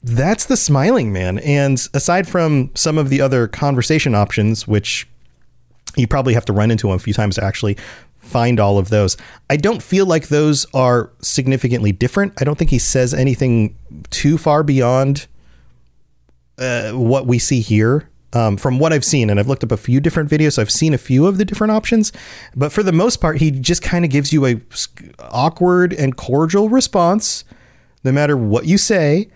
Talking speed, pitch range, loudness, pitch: 190 wpm, 115-155 Hz, -15 LUFS, 135 Hz